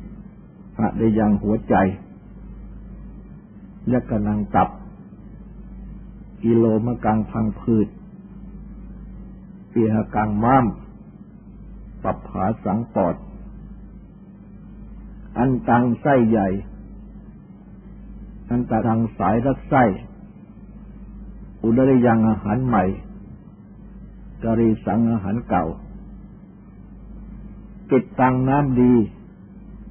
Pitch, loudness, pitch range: 115 Hz, -20 LUFS, 105-125 Hz